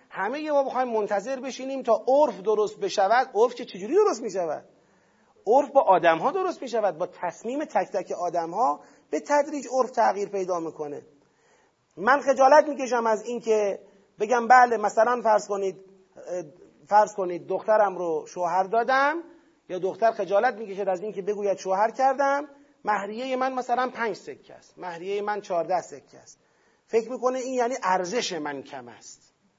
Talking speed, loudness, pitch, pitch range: 160 wpm, -25 LUFS, 220 Hz, 190-260 Hz